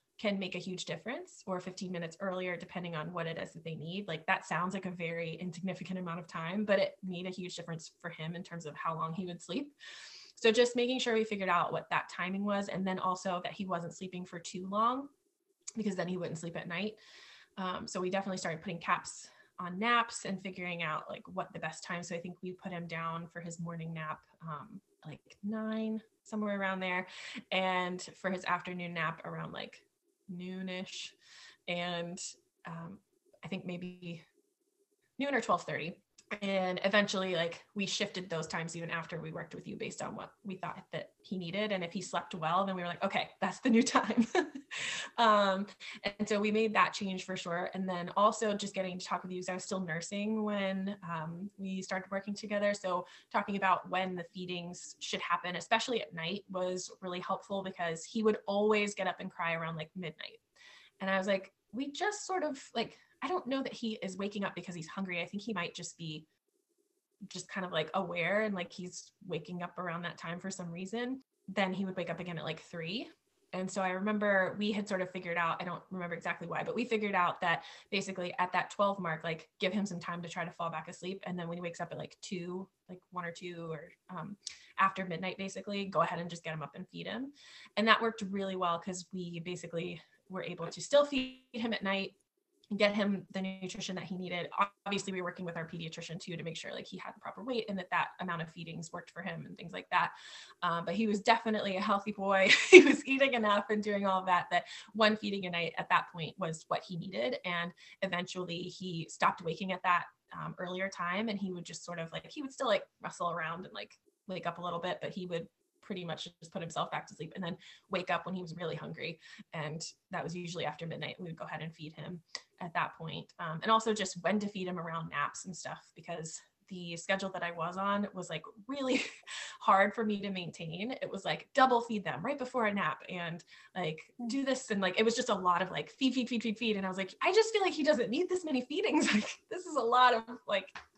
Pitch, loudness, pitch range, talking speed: 185 Hz, -35 LUFS, 170-210 Hz, 235 wpm